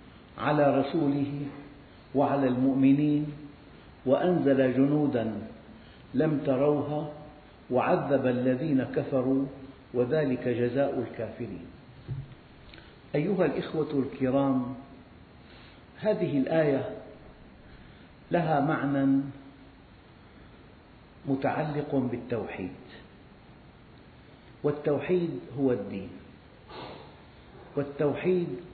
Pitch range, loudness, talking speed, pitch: 125-145 Hz, -28 LUFS, 55 wpm, 135 Hz